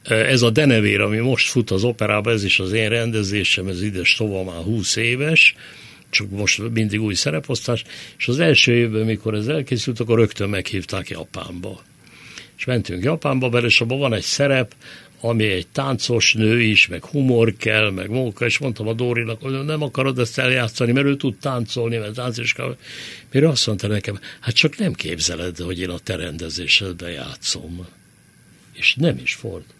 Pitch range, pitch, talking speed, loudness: 100-125 Hz, 115 Hz, 180 wpm, -19 LUFS